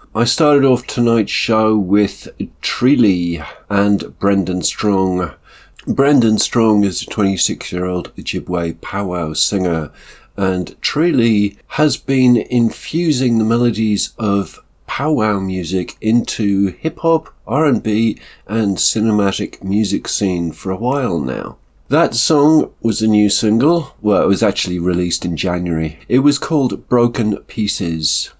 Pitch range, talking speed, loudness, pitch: 90-120 Hz, 120 wpm, -16 LUFS, 105 Hz